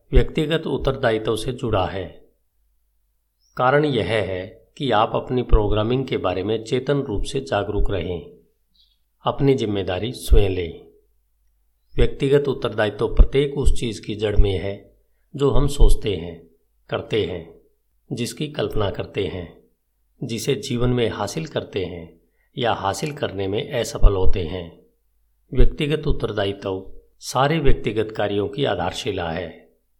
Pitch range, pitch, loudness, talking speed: 95-135 Hz, 110 Hz, -23 LUFS, 130 wpm